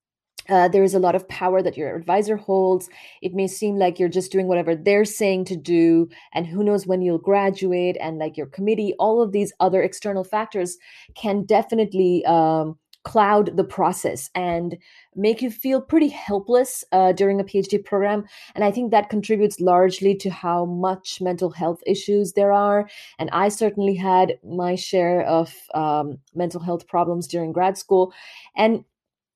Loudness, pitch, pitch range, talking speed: -21 LUFS, 190 Hz, 175-205 Hz, 175 wpm